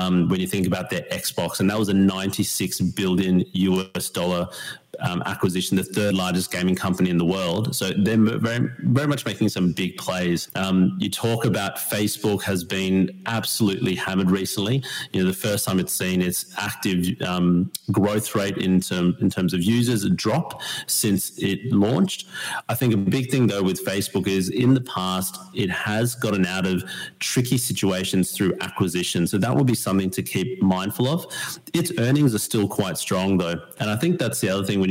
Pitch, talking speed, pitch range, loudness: 95 Hz, 185 wpm, 95-110 Hz, -23 LUFS